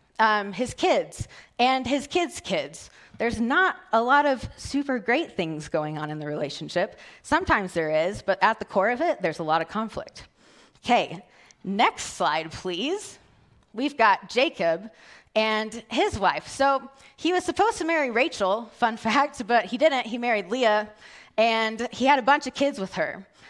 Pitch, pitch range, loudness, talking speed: 230 Hz, 195-280 Hz, -25 LUFS, 175 wpm